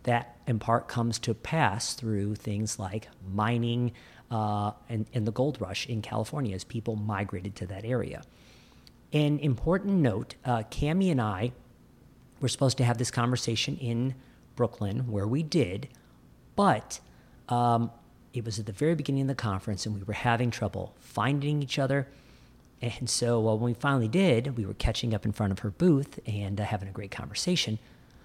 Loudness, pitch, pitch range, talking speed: -29 LUFS, 120 Hz, 105-130 Hz, 175 wpm